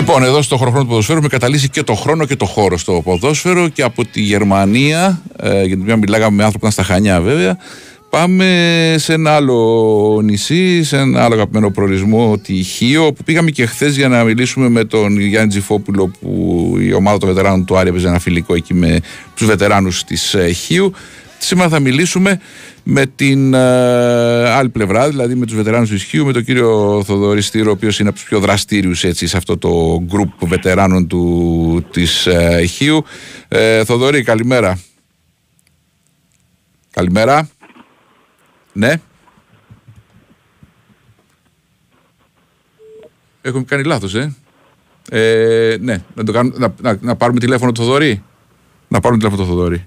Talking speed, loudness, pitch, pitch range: 155 wpm, -13 LUFS, 115 Hz, 100-140 Hz